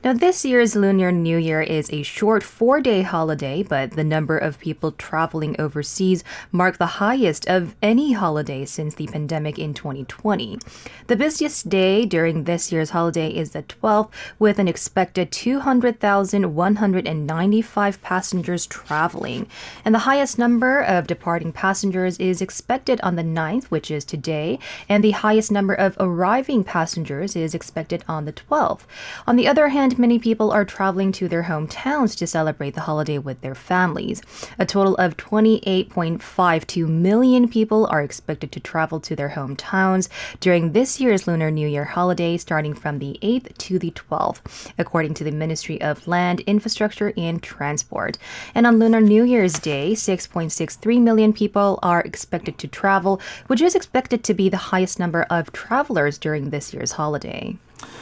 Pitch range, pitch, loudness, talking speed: 160-215 Hz, 185 Hz, -20 LUFS, 160 wpm